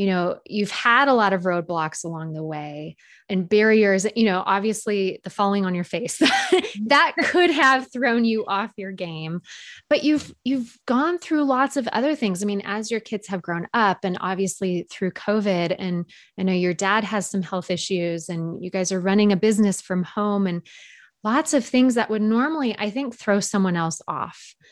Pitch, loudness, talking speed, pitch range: 200 Hz, -22 LUFS, 195 wpm, 185-235 Hz